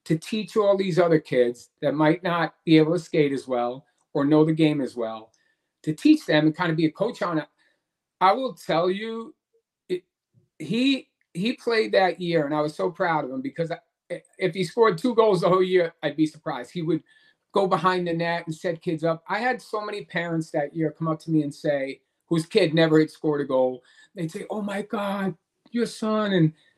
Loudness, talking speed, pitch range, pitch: -24 LUFS, 225 wpm, 155-205 Hz, 170 Hz